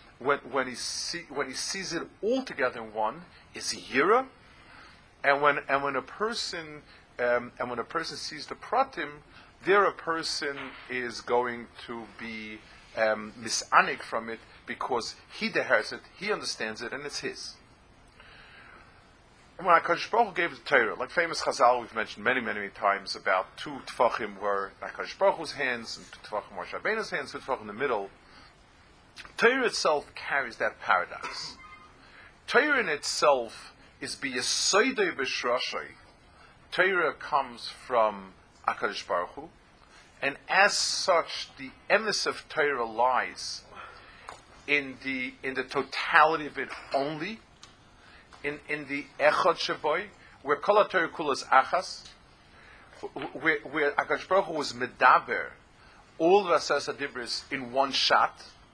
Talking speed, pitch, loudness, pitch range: 135 wpm, 130 Hz, -28 LUFS, 110-150 Hz